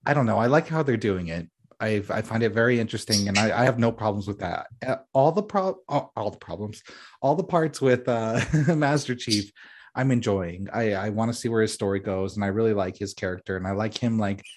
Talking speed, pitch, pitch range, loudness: 245 wpm, 110 Hz, 100-125 Hz, -25 LUFS